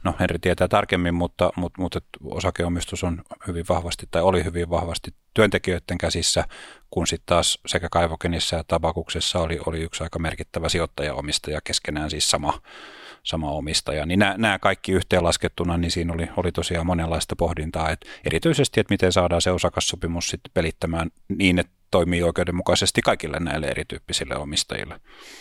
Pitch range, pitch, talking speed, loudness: 80-90 Hz, 85 Hz, 150 wpm, -23 LUFS